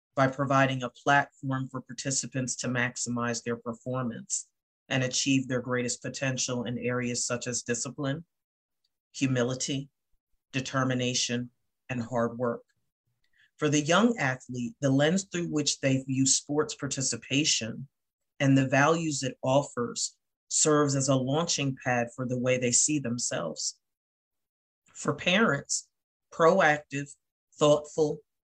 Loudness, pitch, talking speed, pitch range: -28 LUFS, 130 Hz, 120 wpm, 125-140 Hz